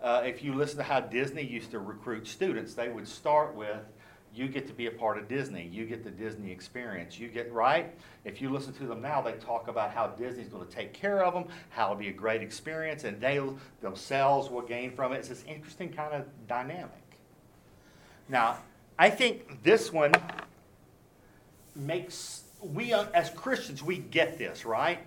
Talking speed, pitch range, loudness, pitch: 195 wpm, 115-150 Hz, -31 LUFS, 130 Hz